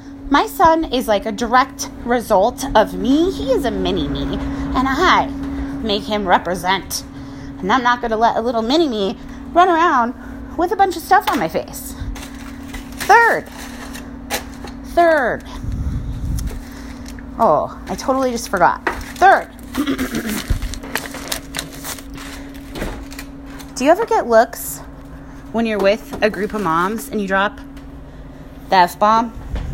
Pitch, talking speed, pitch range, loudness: 255 Hz, 130 wpm, 210-275 Hz, -17 LUFS